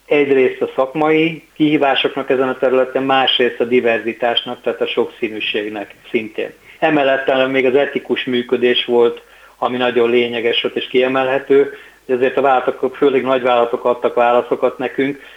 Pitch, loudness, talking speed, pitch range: 130 Hz, -16 LUFS, 135 wpm, 125-150 Hz